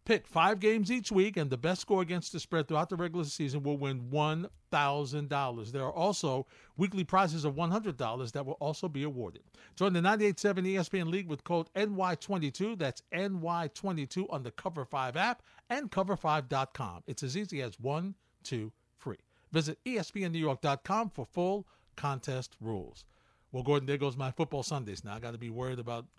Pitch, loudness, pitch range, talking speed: 155 Hz, -33 LUFS, 135-190 Hz, 180 wpm